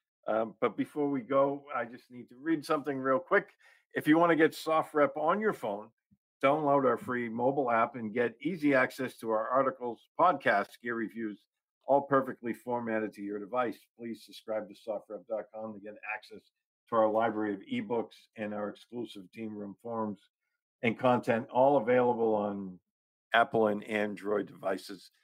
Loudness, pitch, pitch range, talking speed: -31 LUFS, 120 Hz, 110-140 Hz, 165 wpm